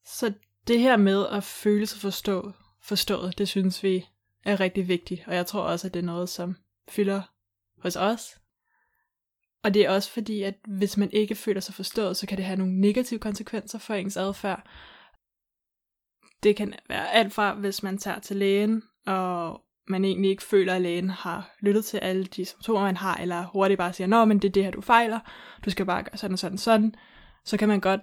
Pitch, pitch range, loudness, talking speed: 195 Hz, 185-210 Hz, -26 LUFS, 210 wpm